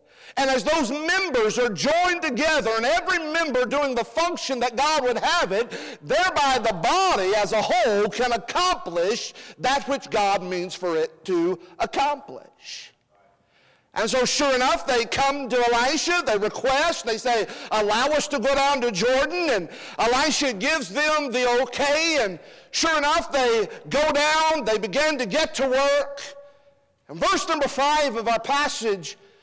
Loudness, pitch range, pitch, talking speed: -22 LUFS, 240-315 Hz, 275 Hz, 160 wpm